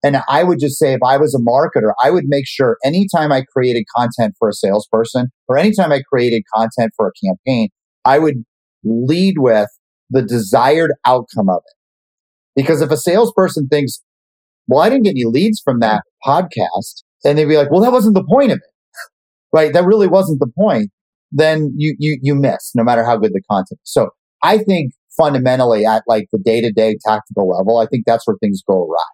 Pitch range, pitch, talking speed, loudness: 115-160 Hz, 135 Hz, 205 wpm, -14 LUFS